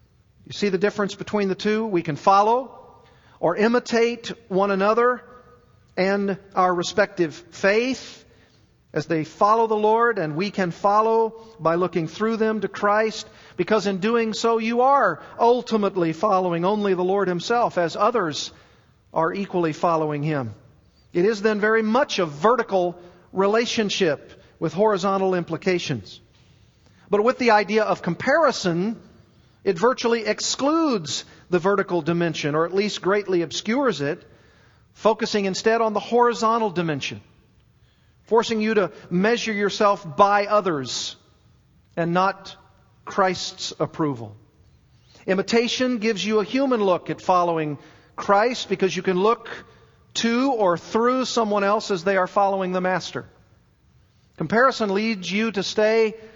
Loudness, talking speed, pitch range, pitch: -22 LUFS, 135 wpm, 175-220 Hz, 200 Hz